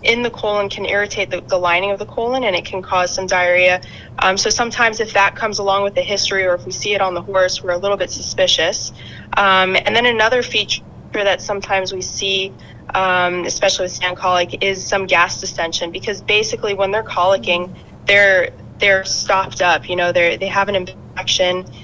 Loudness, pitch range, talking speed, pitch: -16 LUFS, 180-200 Hz, 205 wpm, 190 Hz